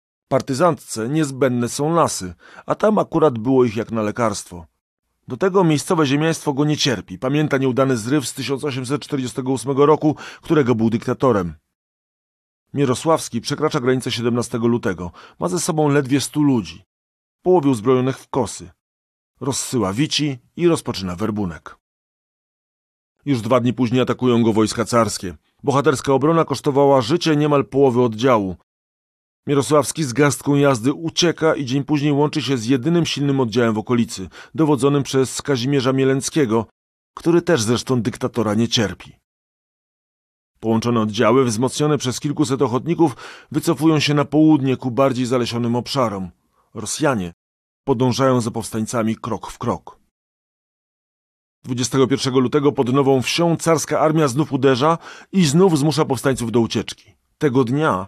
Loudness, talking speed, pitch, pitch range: -19 LUFS, 130 wpm, 135 Hz, 115-150 Hz